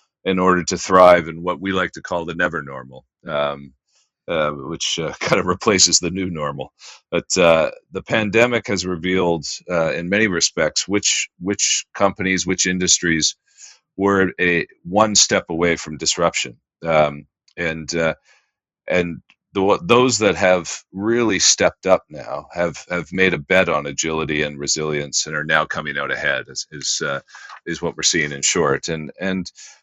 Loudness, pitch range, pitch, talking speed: -18 LUFS, 80-95 Hz, 85 Hz, 165 wpm